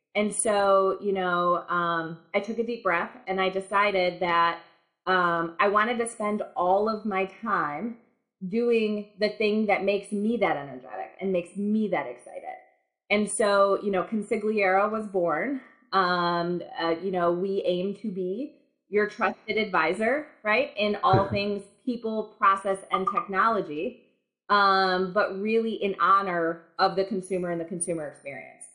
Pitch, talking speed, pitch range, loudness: 195 Hz, 155 wpm, 180-215 Hz, -26 LUFS